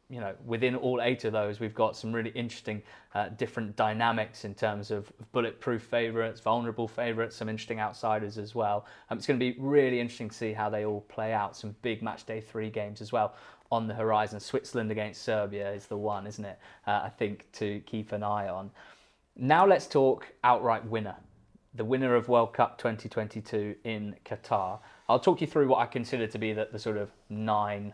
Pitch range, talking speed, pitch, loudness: 105-120 Hz, 205 wpm, 110 Hz, -31 LUFS